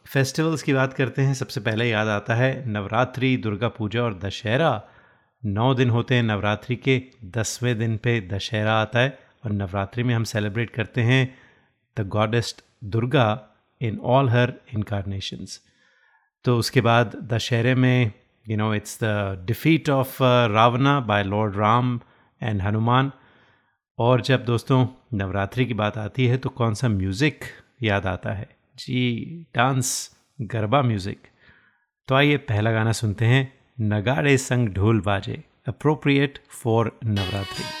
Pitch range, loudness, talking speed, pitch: 105-130 Hz, -23 LUFS, 145 wpm, 120 Hz